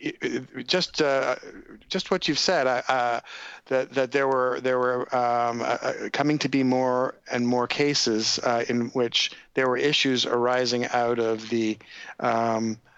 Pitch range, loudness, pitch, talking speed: 120-135 Hz, -24 LUFS, 125 Hz, 155 wpm